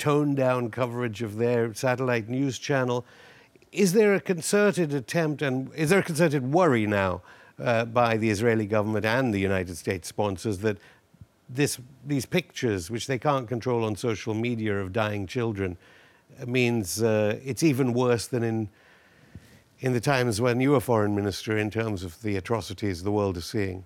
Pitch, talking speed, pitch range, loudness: 120 Hz, 170 wpm, 105-135 Hz, -26 LUFS